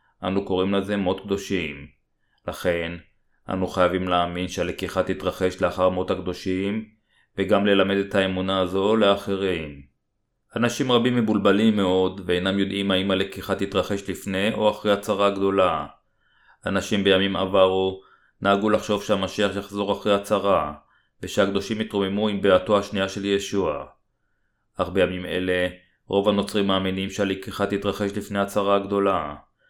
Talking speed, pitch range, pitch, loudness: 125 wpm, 95-100 Hz, 100 Hz, -23 LUFS